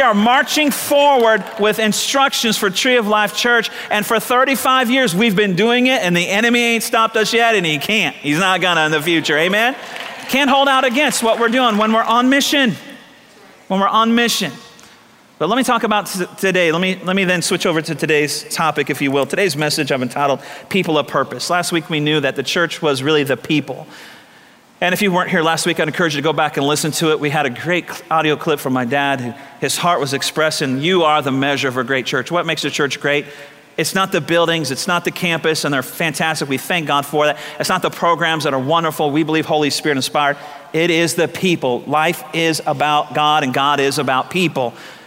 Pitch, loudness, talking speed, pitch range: 165 Hz, -16 LUFS, 230 wpm, 150-210 Hz